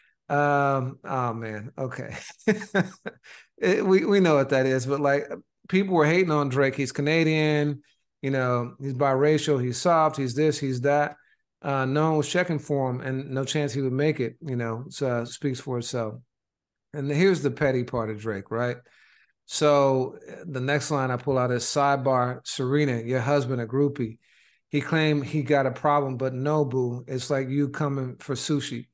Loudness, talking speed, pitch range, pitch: -25 LUFS, 180 wpm, 130-150 Hz, 140 Hz